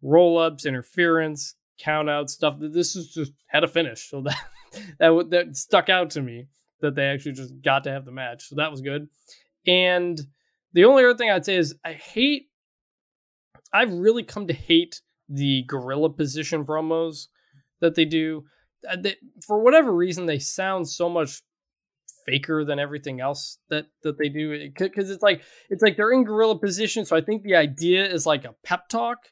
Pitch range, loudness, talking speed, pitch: 145-185 Hz, -22 LUFS, 185 wpm, 160 Hz